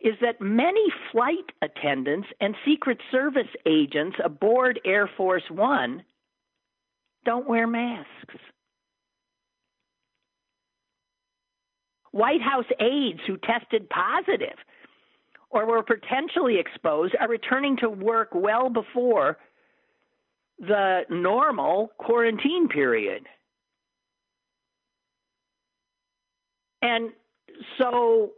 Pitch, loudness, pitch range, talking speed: 240 Hz, -24 LUFS, 220-340 Hz, 80 wpm